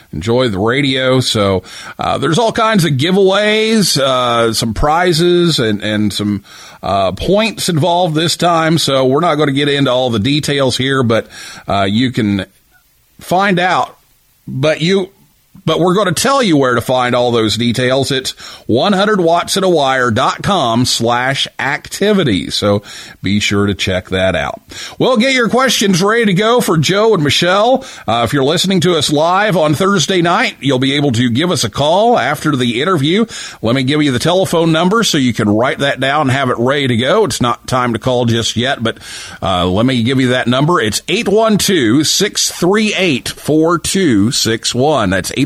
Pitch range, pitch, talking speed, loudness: 120-185 Hz, 140 Hz, 180 wpm, -13 LUFS